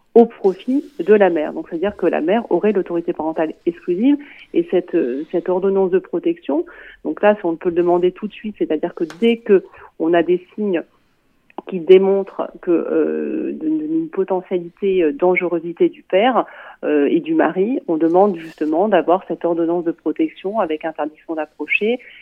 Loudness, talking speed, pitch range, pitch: -18 LUFS, 170 wpm, 170-235 Hz, 185 Hz